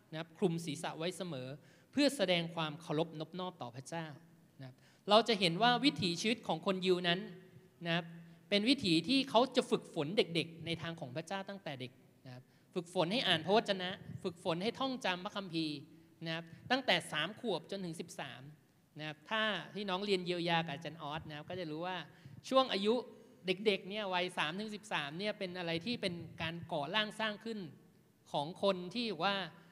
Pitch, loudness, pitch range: 180 Hz, -36 LUFS, 160-200 Hz